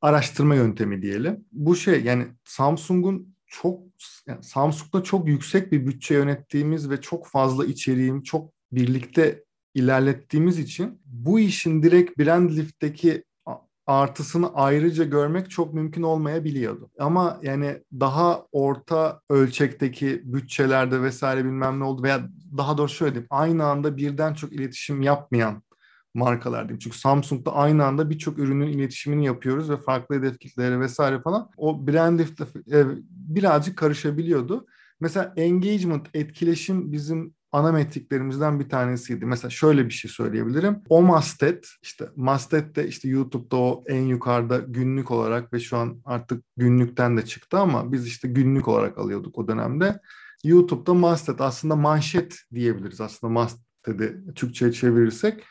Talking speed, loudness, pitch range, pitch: 135 wpm, -23 LUFS, 130-165 Hz, 145 Hz